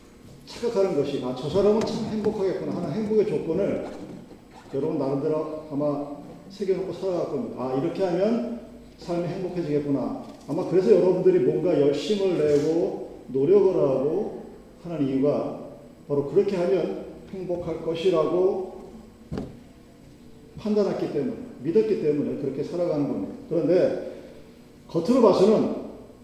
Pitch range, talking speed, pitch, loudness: 150-210 Hz, 300 characters per minute, 180 Hz, -24 LUFS